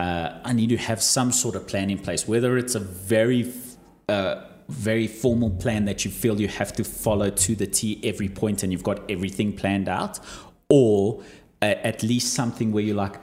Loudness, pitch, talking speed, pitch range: -24 LUFS, 110 Hz, 205 wpm, 100-115 Hz